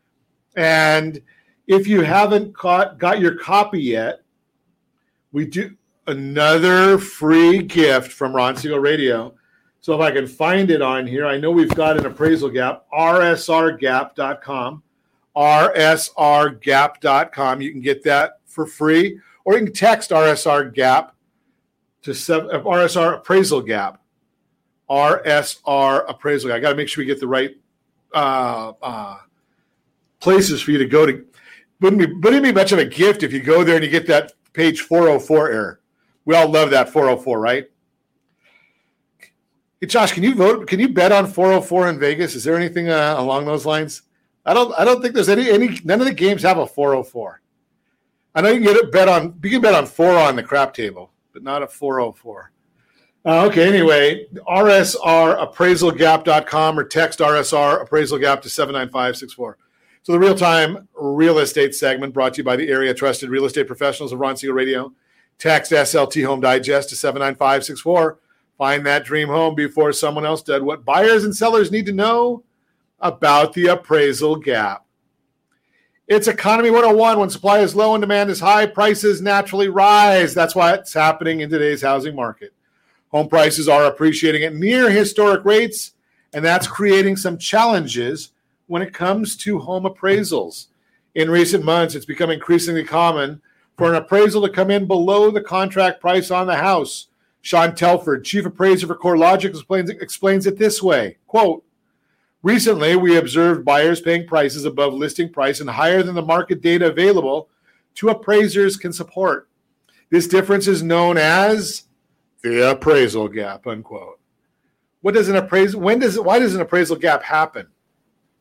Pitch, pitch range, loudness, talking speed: 165 Hz, 145-195 Hz, -16 LUFS, 160 wpm